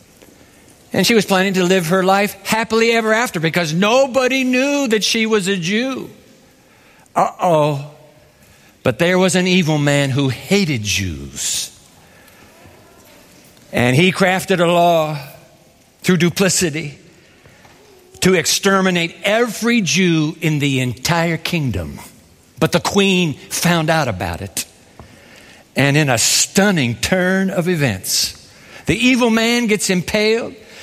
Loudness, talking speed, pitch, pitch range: -16 LUFS, 125 wpm, 175 Hz, 145-200 Hz